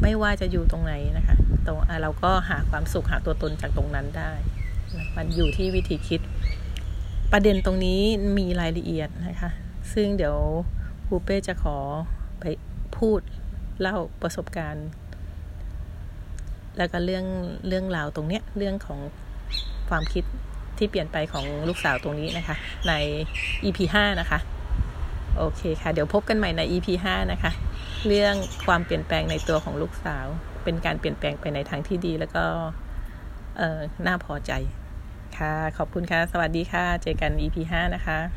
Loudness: -26 LUFS